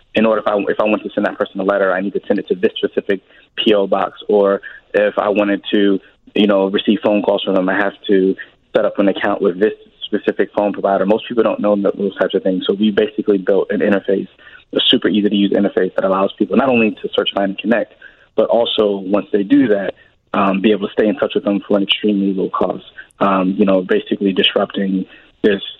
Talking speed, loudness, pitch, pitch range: 240 wpm, -16 LUFS, 100 Hz, 95-105 Hz